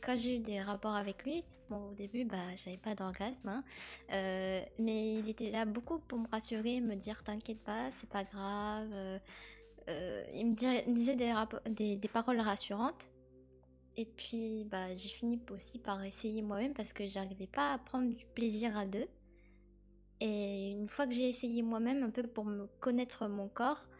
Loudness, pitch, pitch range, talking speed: -39 LUFS, 220 Hz, 200-240 Hz, 190 wpm